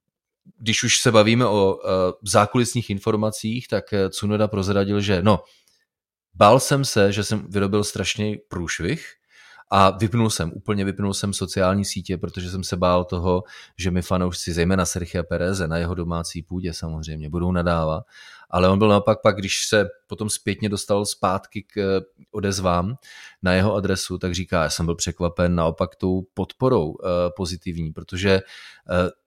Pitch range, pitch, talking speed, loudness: 90-105 Hz, 95 Hz, 150 wpm, -22 LUFS